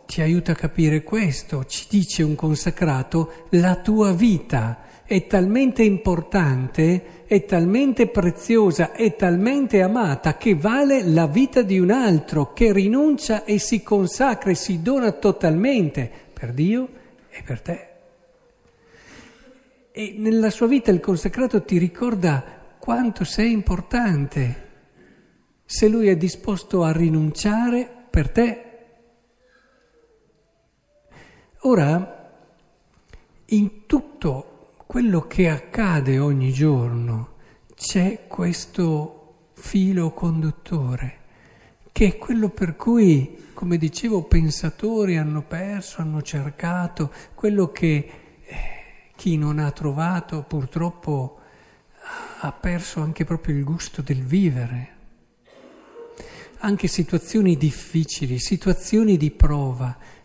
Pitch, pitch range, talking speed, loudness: 180 Hz, 155-220 Hz, 105 wpm, -21 LUFS